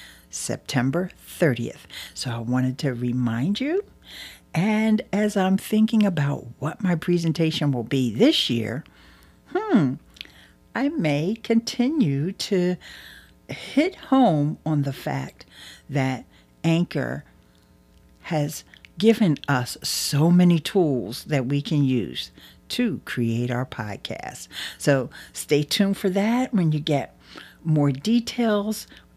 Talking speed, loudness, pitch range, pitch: 115 wpm, -23 LUFS, 130-205 Hz, 160 Hz